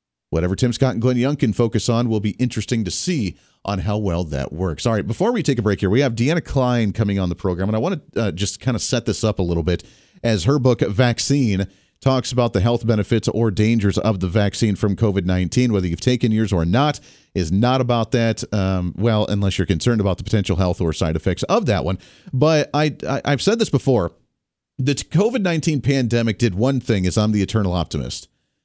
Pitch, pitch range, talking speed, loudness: 110 Hz, 95-125 Hz, 225 wpm, -20 LUFS